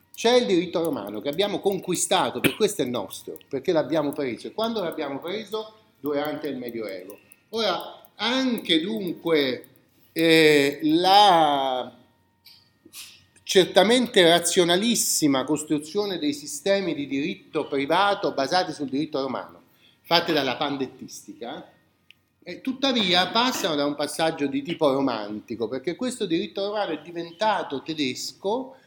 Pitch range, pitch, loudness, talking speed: 140-205 Hz, 165 Hz, -23 LUFS, 120 wpm